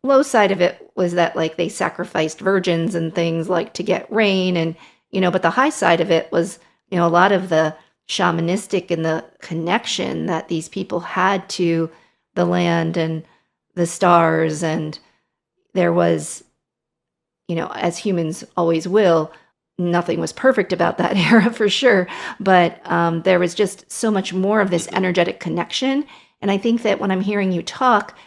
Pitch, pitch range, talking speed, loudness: 175 Hz, 165-195 Hz, 180 wpm, -19 LUFS